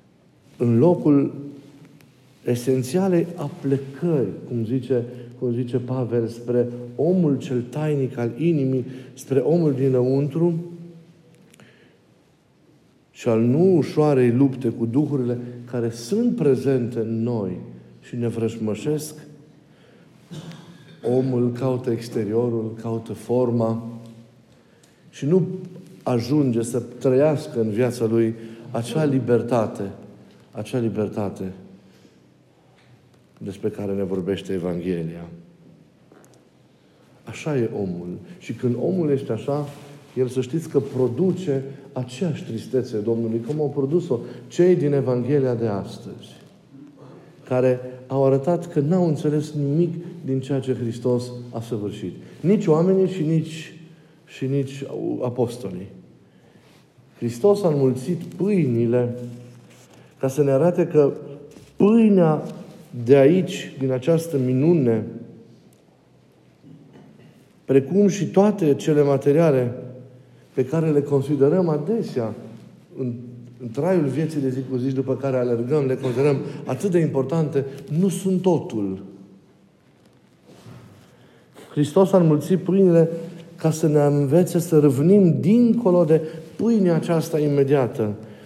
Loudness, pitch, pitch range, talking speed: -21 LUFS, 135 Hz, 120-160 Hz, 105 wpm